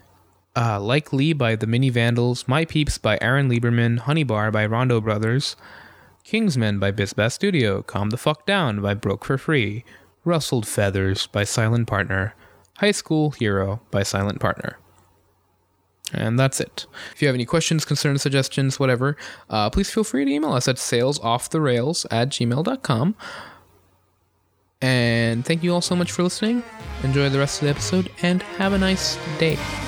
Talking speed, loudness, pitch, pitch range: 165 wpm, -22 LUFS, 120 Hz, 100-150 Hz